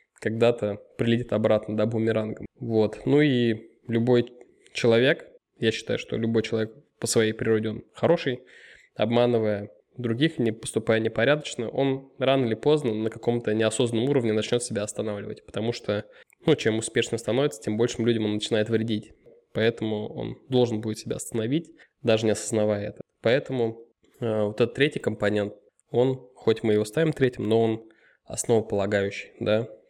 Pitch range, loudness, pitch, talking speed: 110-125 Hz, -26 LUFS, 115 Hz, 150 wpm